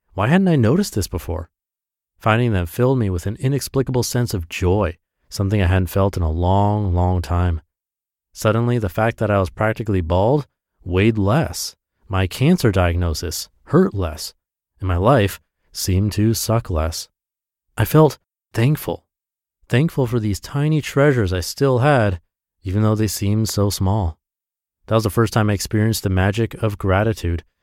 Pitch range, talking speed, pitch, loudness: 90-115 Hz, 165 wpm, 100 Hz, -19 LUFS